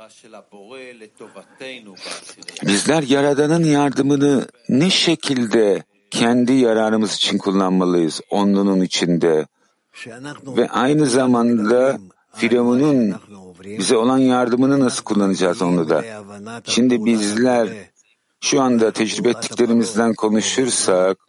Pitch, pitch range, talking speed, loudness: 115 Hz, 100-130 Hz, 80 wpm, -17 LUFS